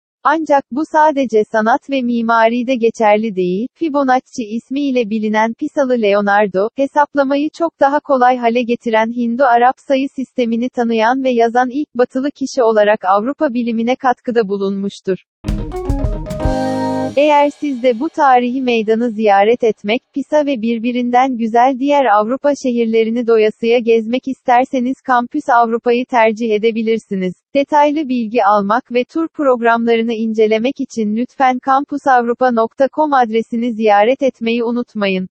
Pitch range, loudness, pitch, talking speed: 225-270 Hz, -15 LUFS, 245 Hz, 120 wpm